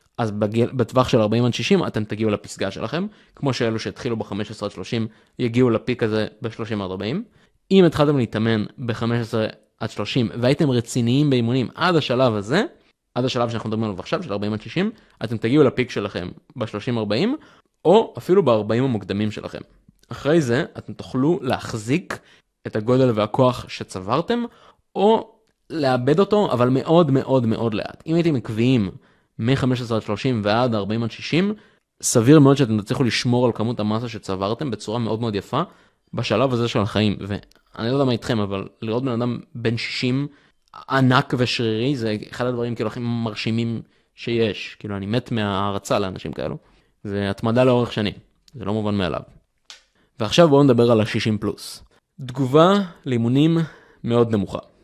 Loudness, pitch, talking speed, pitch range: -21 LUFS, 120 Hz, 155 wpm, 110-135 Hz